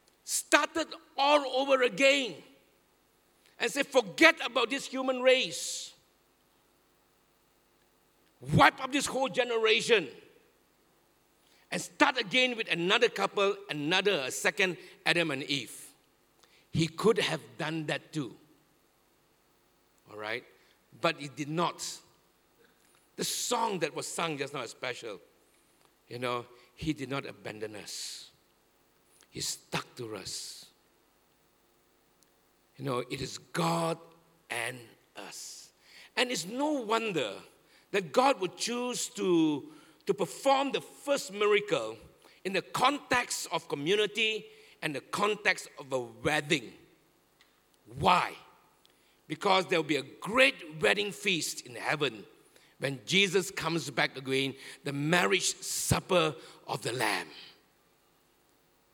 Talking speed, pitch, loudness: 115 wpm, 185 Hz, -30 LUFS